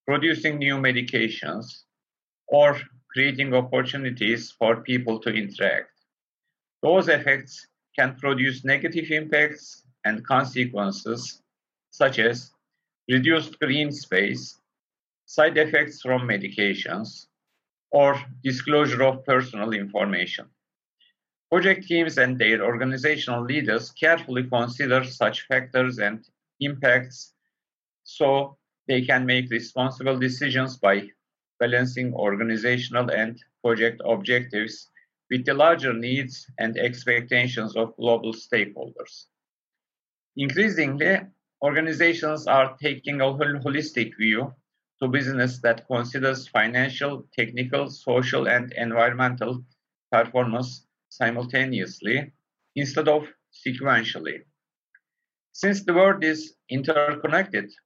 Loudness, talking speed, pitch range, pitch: -23 LUFS, 95 wpm, 120-145 Hz, 130 Hz